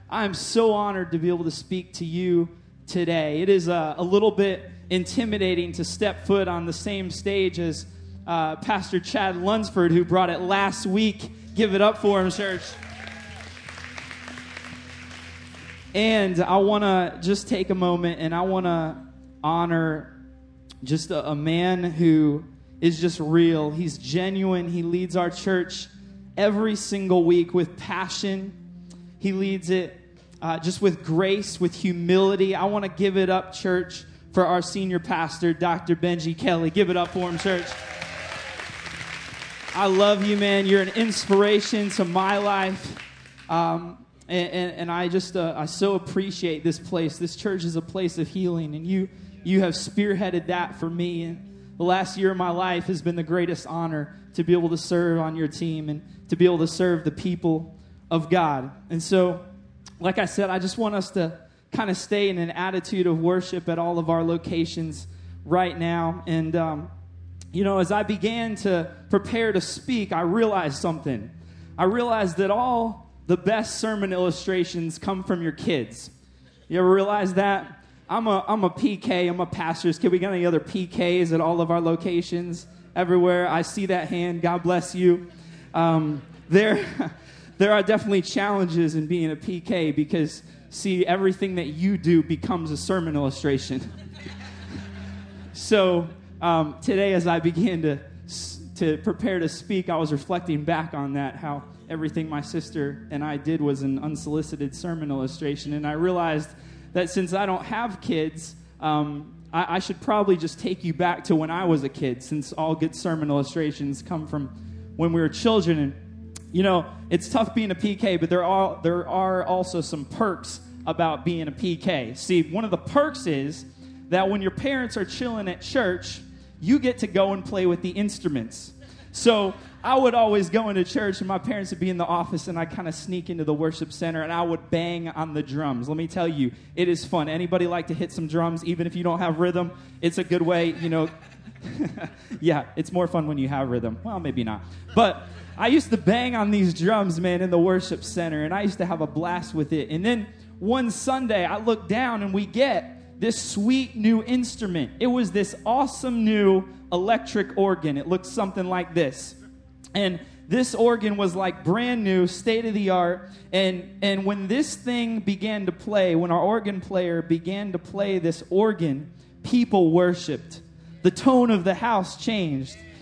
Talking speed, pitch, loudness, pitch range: 185 wpm, 175 Hz, -24 LUFS, 160-195 Hz